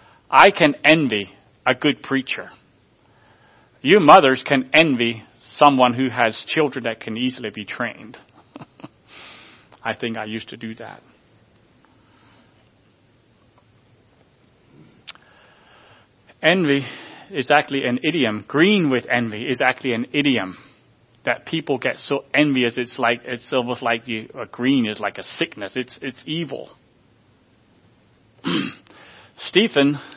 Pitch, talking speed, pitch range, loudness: 125 Hz, 115 wpm, 115-140 Hz, -19 LUFS